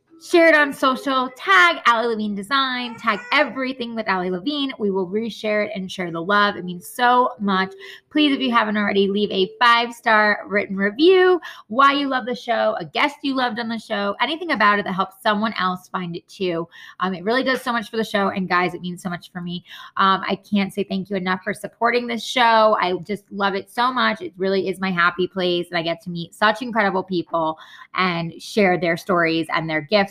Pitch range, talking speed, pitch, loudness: 185-240 Hz, 225 wpm, 205 Hz, -20 LUFS